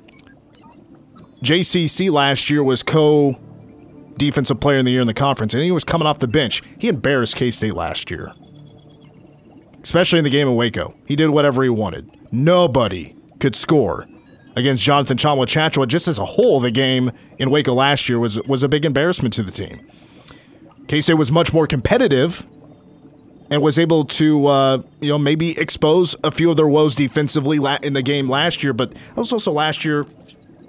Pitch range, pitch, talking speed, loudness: 135-155 Hz, 145 Hz, 175 wpm, -16 LUFS